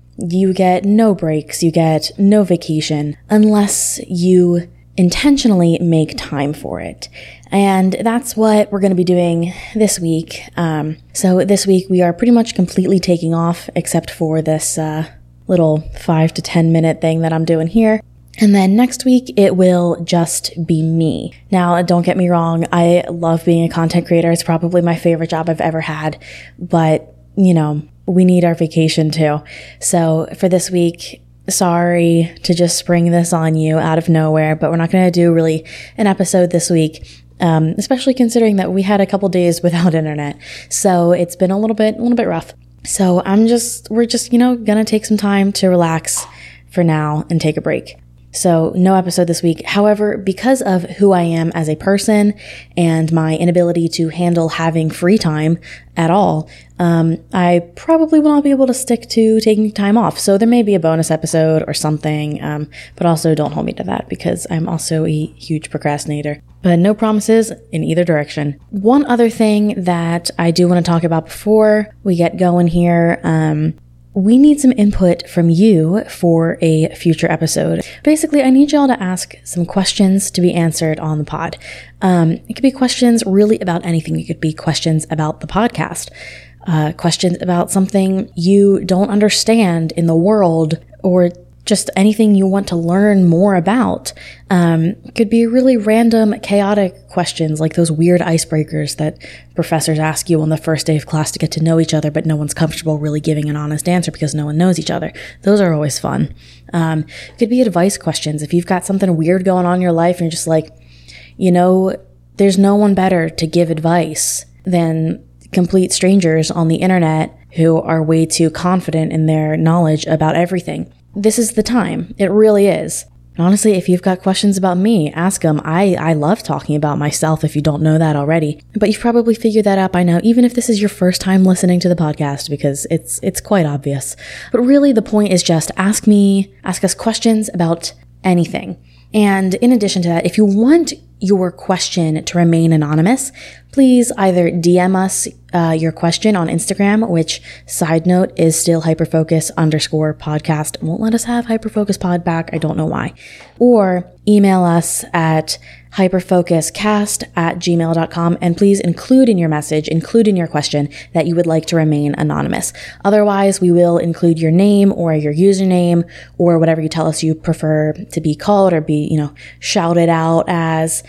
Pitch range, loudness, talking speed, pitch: 160-195 Hz, -14 LUFS, 190 wpm, 170 Hz